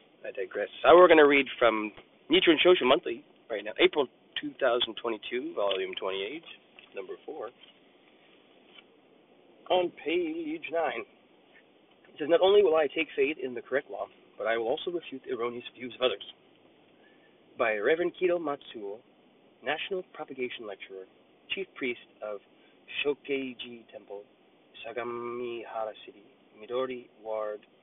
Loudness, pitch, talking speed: -28 LUFS, 165 Hz, 130 wpm